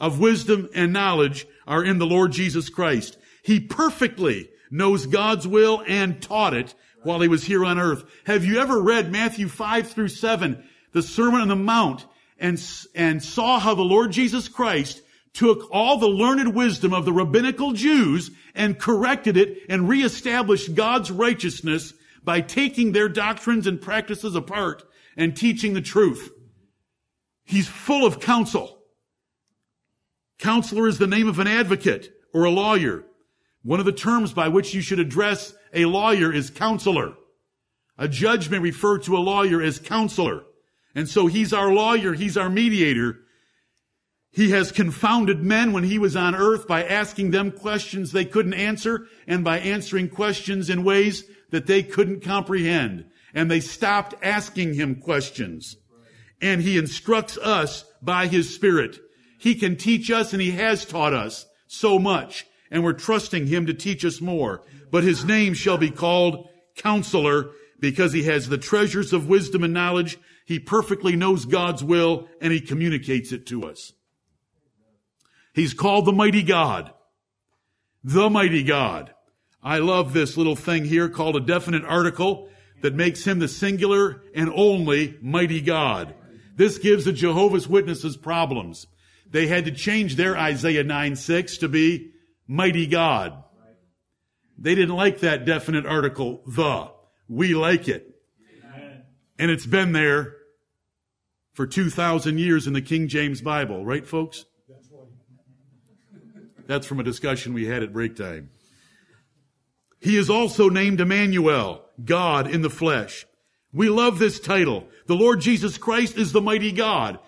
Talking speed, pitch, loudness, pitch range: 155 wpm, 180 Hz, -21 LUFS, 155-205 Hz